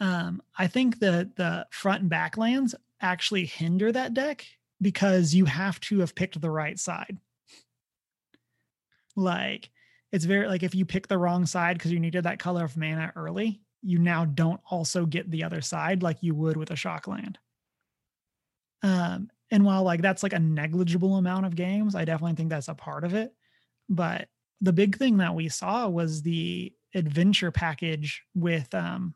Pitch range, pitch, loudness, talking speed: 165-195 Hz, 180 Hz, -27 LUFS, 180 wpm